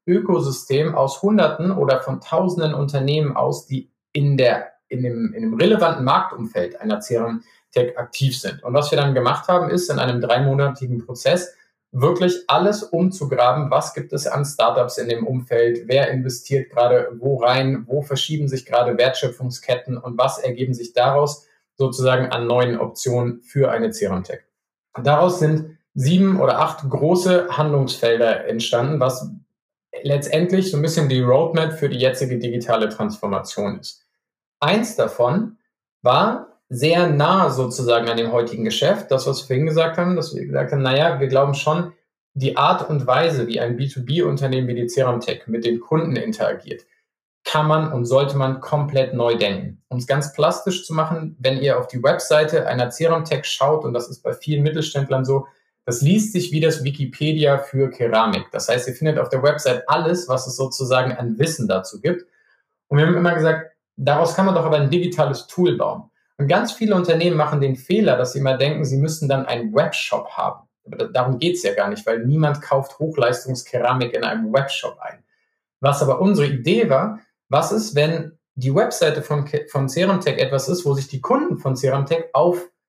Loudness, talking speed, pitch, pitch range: -19 LUFS, 180 wpm, 140 Hz, 125-160 Hz